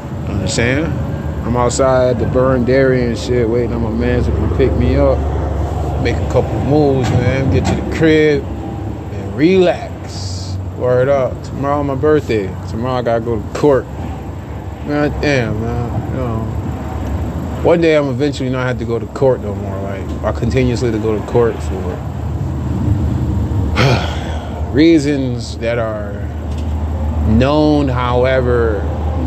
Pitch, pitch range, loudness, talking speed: 110 Hz, 95-130 Hz, -16 LUFS, 140 wpm